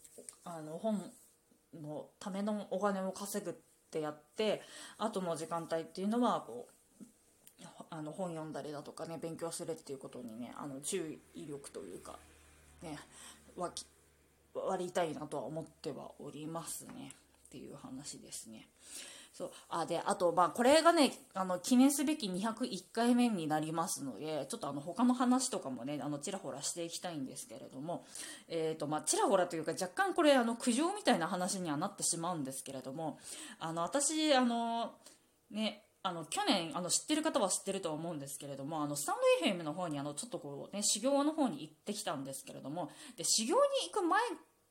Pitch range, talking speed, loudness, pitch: 155-235 Hz, 355 characters per minute, -36 LUFS, 180 Hz